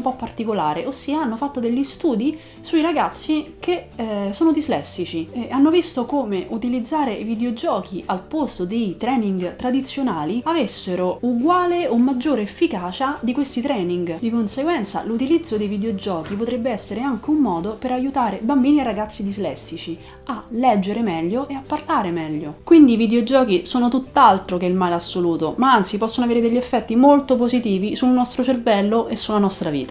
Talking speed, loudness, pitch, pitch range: 160 wpm, -20 LUFS, 240 Hz, 200-270 Hz